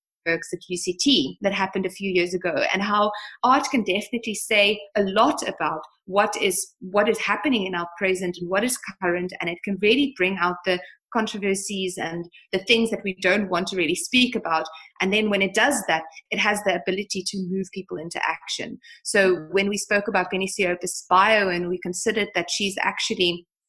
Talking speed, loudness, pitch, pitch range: 195 wpm, -23 LUFS, 195 Hz, 180-210 Hz